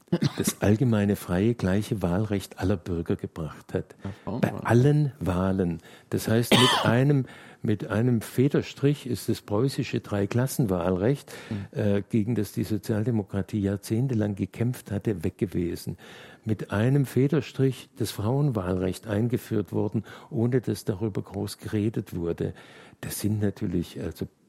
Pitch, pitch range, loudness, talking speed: 110 Hz, 100-120 Hz, -27 LUFS, 125 wpm